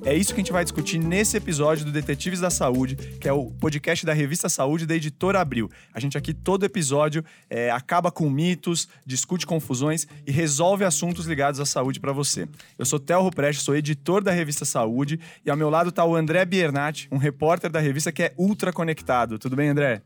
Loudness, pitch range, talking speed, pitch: -24 LUFS, 145-175 Hz, 205 wpm, 155 Hz